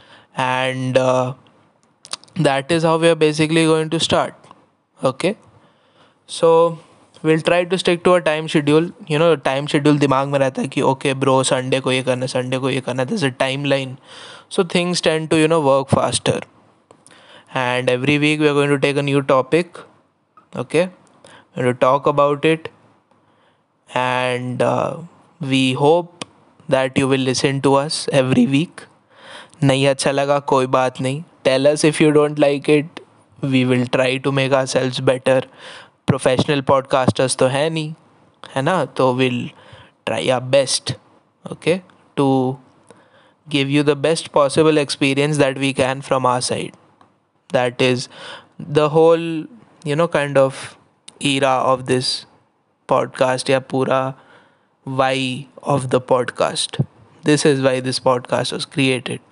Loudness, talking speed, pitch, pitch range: -18 LUFS, 145 wpm, 140 Hz, 130-155 Hz